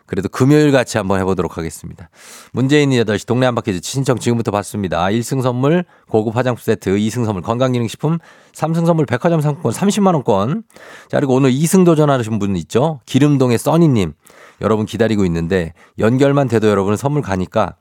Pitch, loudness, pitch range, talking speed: 120 Hz, -16 LUFS, 105-145 Hz, 390 characters per minute